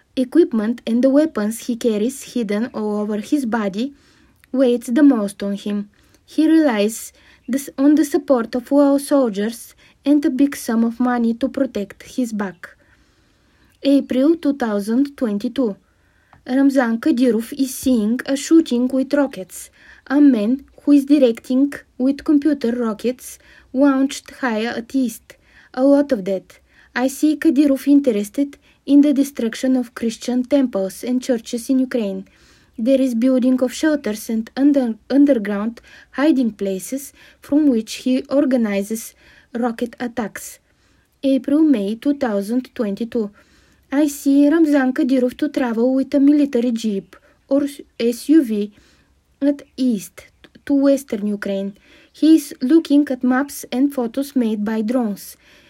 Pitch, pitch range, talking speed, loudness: 260 Hz, 230-280 Hz, 130 wpm, -18 LUFS